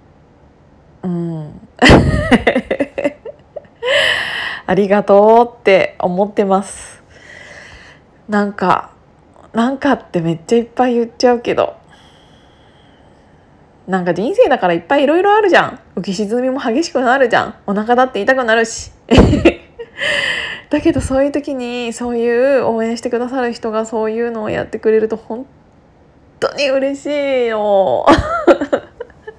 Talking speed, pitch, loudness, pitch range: 255 characters per minute, 235 Hz, -14 LUFS, 205-265 Hz